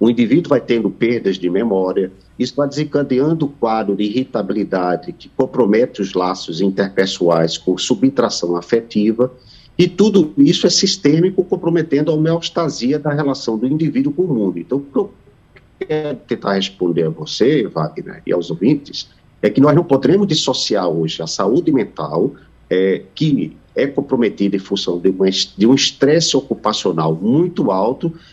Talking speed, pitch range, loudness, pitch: 155 wpm, 95-150 Hz, -16 LUFS, 125 Hz